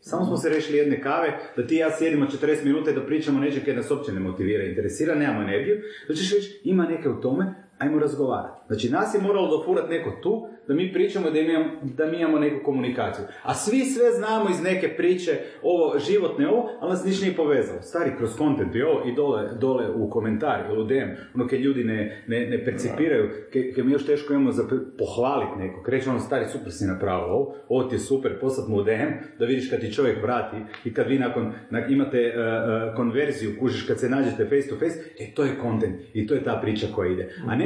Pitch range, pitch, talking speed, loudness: 130-180 Hz, 145 Hz, 225 wpm, -25 LUFS